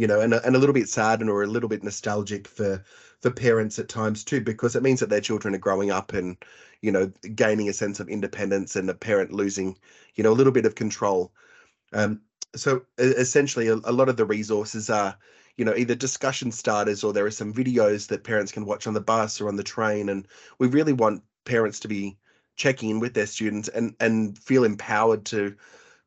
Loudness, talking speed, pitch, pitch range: -24 LUFS, 225 wpm, 110 Hz, 105-120 Hz